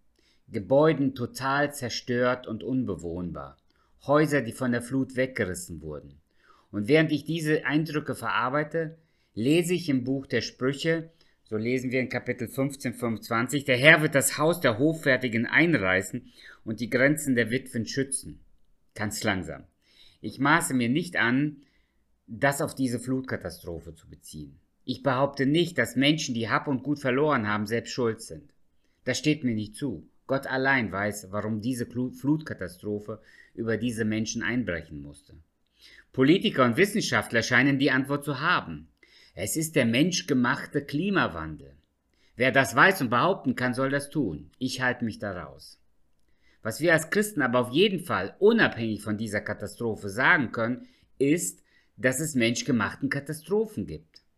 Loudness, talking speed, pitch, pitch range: -26 LUFS, 150 wpm, 125 Hz, 110-140 Hz